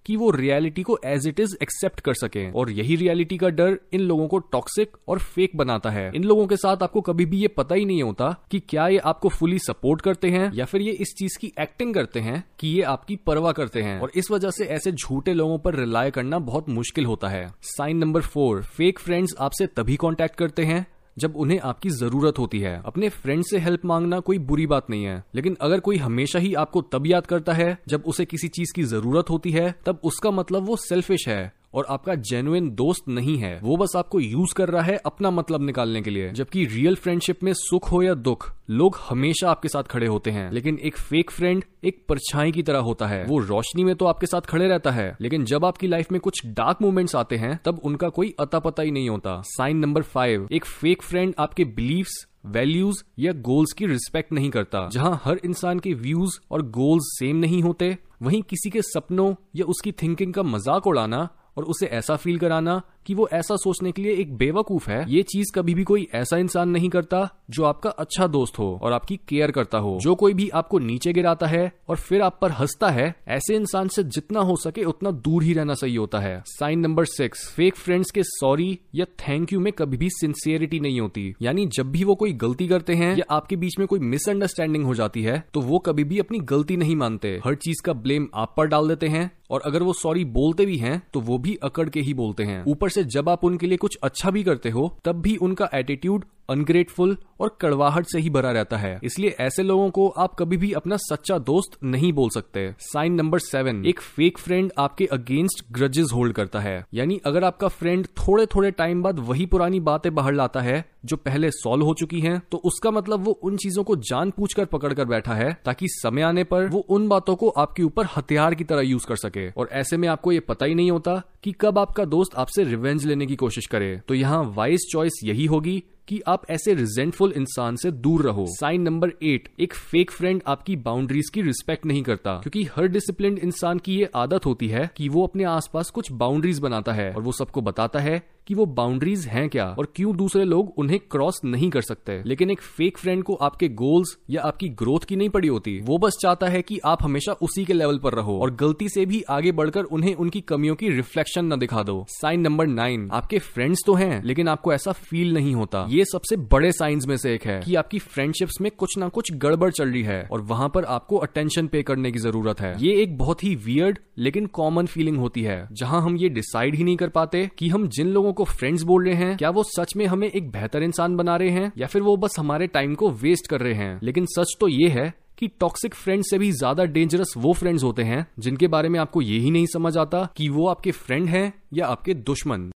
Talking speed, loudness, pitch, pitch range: 225 wpm, -23 LUFS, 165 Hz, 135-185 Hz